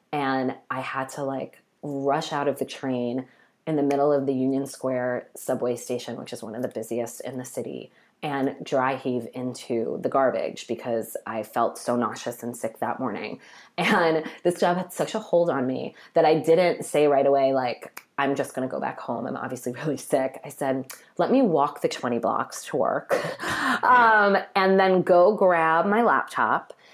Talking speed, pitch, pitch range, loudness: 190 wpm, 135 Hz, 125-165 Hz, -24 LUFS